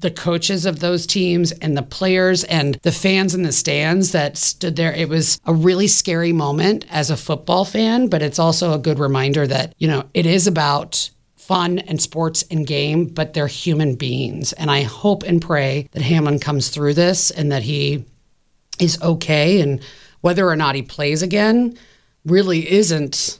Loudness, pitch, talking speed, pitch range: -17 LUFS, 160 Hz, 185 wpm, 145-180 Hz